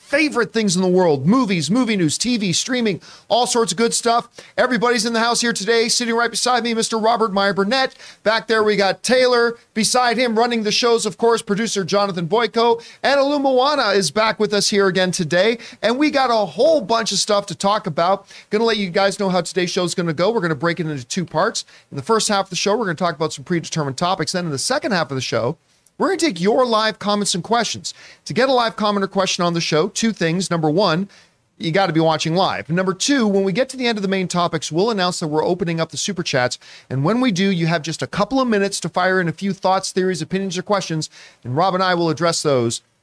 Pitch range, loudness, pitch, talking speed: 175-230 Hz, -18 LUFS, 200 Hz, 255 wpm